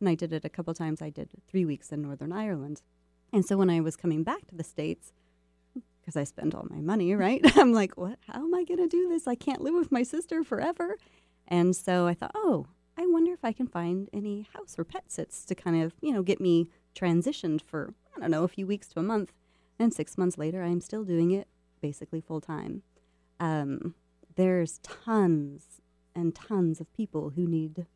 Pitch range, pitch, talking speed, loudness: 155-210 Hz, 175 Hz, 215 wpm, -29 LUFS